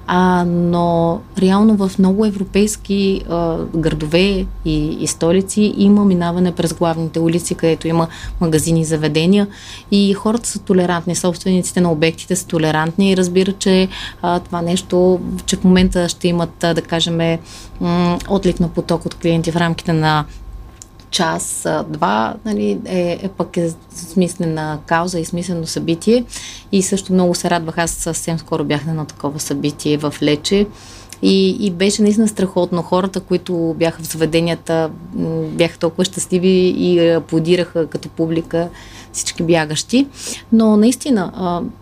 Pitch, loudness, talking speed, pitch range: 175 Hz, -16 LUFS, 145 wpm, 165-190 Hz